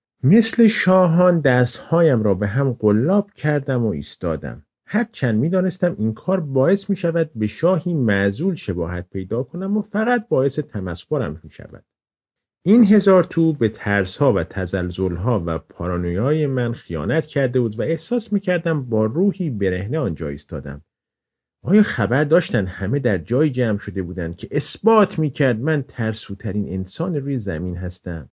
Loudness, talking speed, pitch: -20 LUFS, 150 wpm, 130 Hz